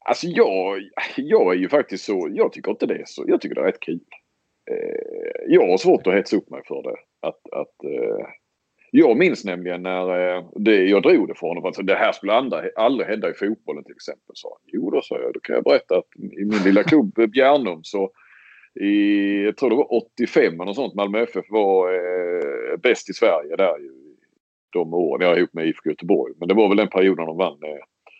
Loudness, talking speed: -20 LUFS, 200 wpm